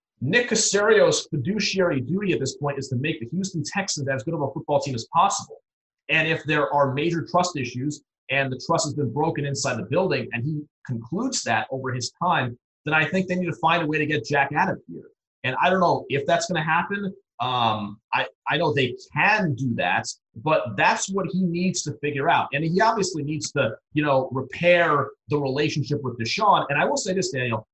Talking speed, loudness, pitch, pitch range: 220 wpm, -23 LUFS, 150 Hz, 135-180 Hz